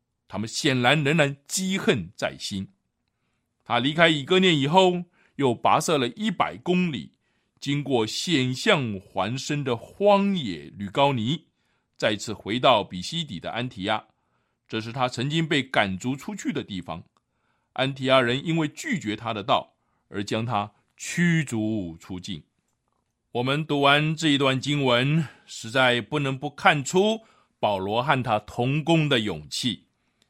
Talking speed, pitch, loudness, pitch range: 210 characters per minute, 135 Hz, -24 LUFS, 110-160 Hz